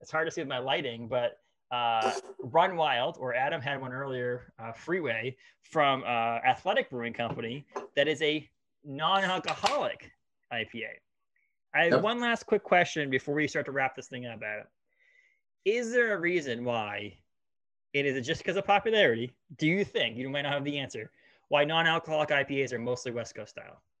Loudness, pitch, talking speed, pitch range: -29 LUFS, 140 Hz, 185 wpm, 125-175 Hz